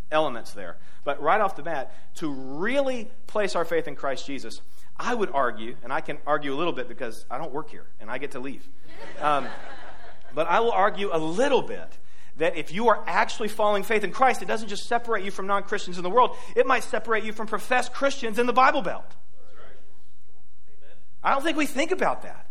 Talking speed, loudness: 215 wpm, -26 LUFS